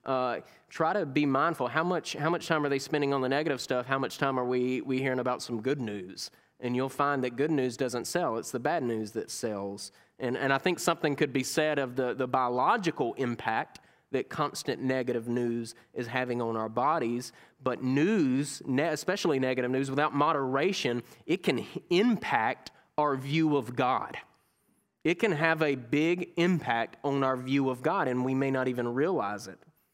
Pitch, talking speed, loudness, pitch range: 135 Hz, 190 wpm, -30 LUFS, 125-150 Hz